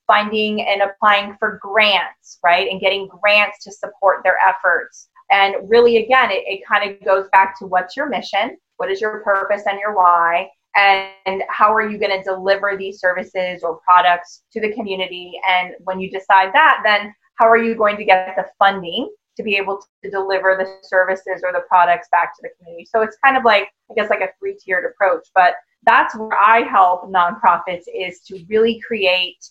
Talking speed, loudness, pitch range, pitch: 200 wpm, -16 LUFS, 185-220 Hz, 195 Hz